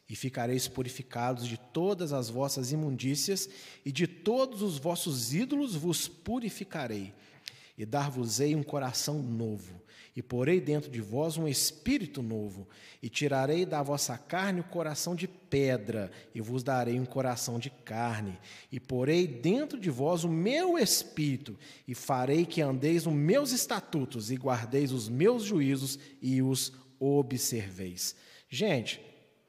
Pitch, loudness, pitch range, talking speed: 140 Hz, -31 LUFS, 125-165 Hz, 140 wpm